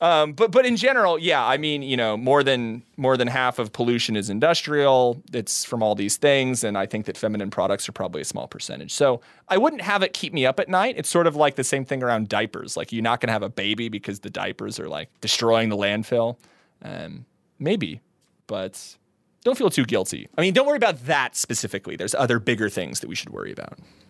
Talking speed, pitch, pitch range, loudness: 230 wpm, 125 Hz, 110-150 Hz, -22 LUFS